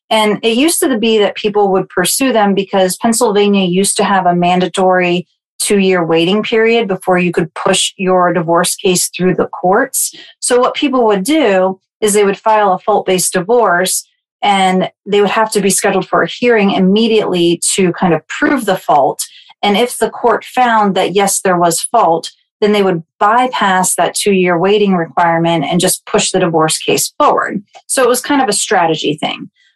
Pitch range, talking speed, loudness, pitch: 180-220 Hz, 190 wpm, -12 LUFS, 195 Hz